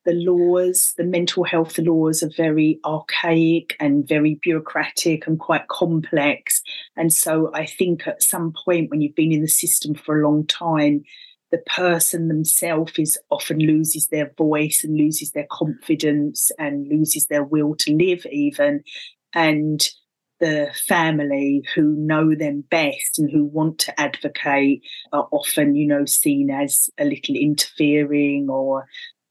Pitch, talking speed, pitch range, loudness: 155 Hz, 145 wpm, 150-175 Hz, -19 LUFS